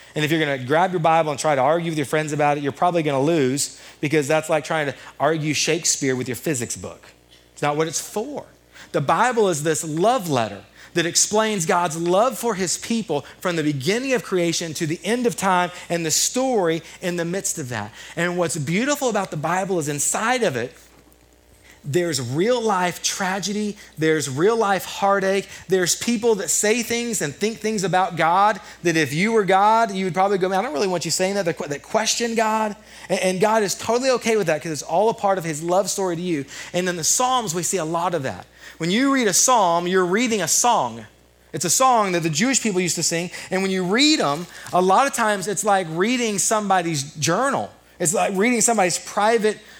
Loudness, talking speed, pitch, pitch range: -20 LUFS, 220 wpm, 180 Hz, 155-210 Hz